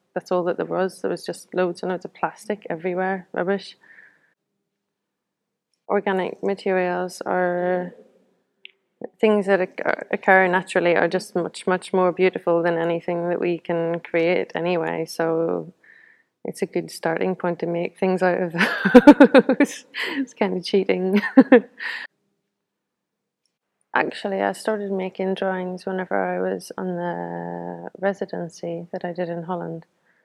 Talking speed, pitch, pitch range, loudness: 135 wpm, 185 Hz, 175-200 Hz, -22 LUFS